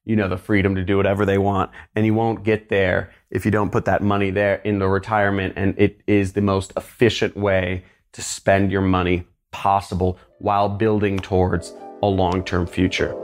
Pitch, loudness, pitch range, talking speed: 100 Hz, -20 LUFS, 95-100 Hz, 195 wpm